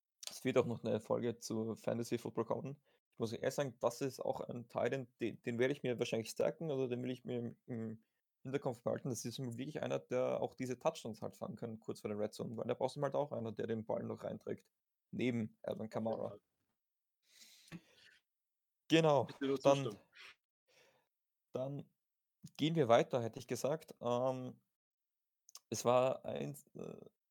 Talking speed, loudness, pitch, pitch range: 180 wpm, -39 LUFS, 125 Hz, 115-135 Hz